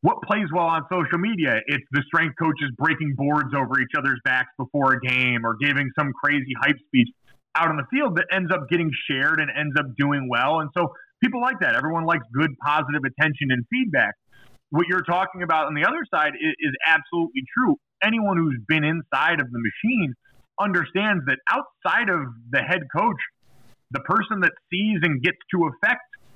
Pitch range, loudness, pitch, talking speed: 140-185 Hz, -22 LUFS, 160 Hz, 195 wpm